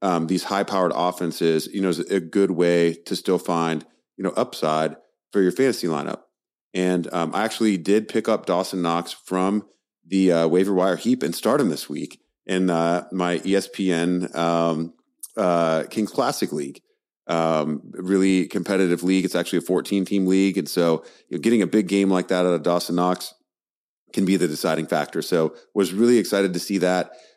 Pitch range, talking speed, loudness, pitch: 85-95 Hz, 185 wpm, -22 LUFS, 90 Hz